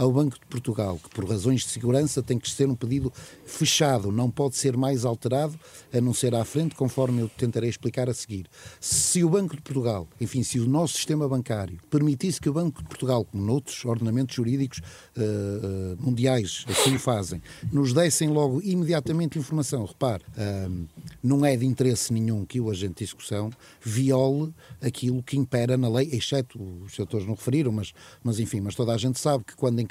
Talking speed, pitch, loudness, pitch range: 195 wpm, 125 Hz, -26 LUFS, 115-140 Hz